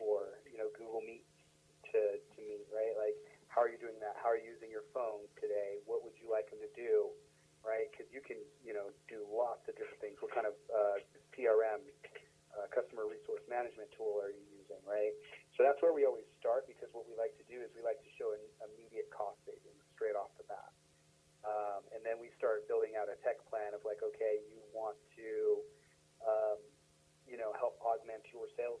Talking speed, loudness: 215 wpm, -40 LUFS